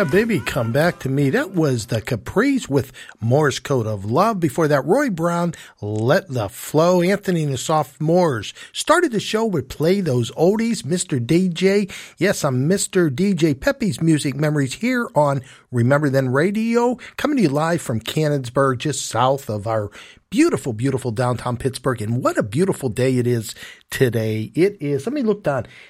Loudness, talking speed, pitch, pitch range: -20 LUFS, 175 wpm, 150 Hz, 130-185 Hz